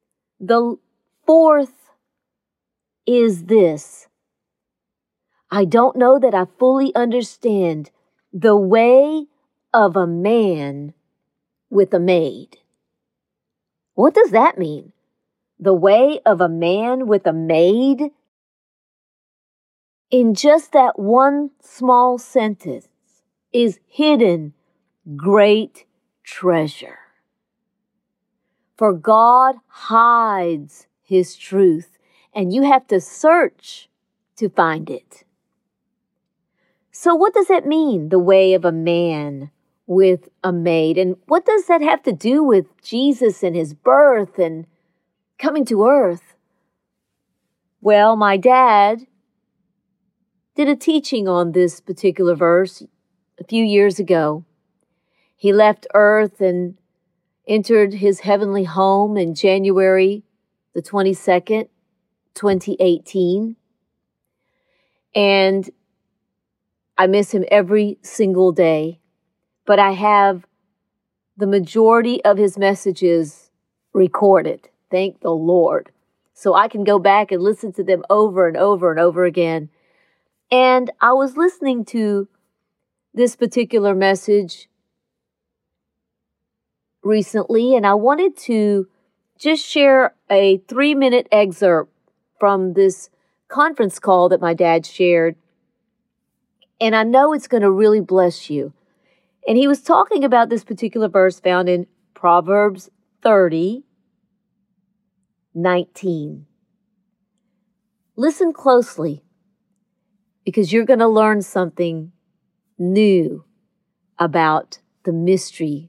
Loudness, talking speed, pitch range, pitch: -16 LUFS, 105 wpm, 180-230 Hz, 200 Hz